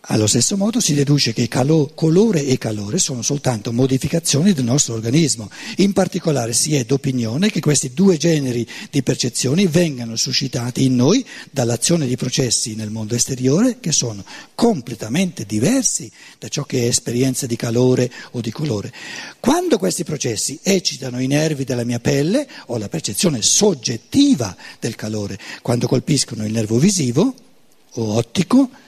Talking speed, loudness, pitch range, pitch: 150 wpm, -18 LUFS, 120-175 Hz, 135 Hz